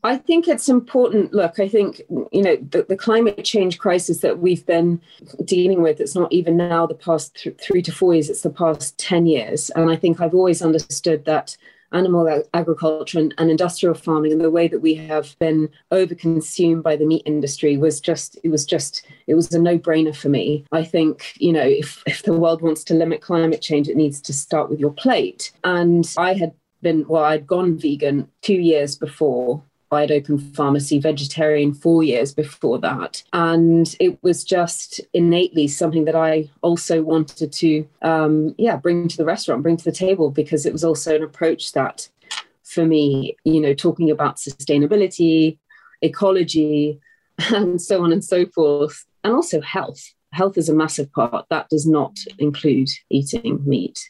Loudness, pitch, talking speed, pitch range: -19 LUFS, 160 Hz, 185 wpm, 150-175 Hz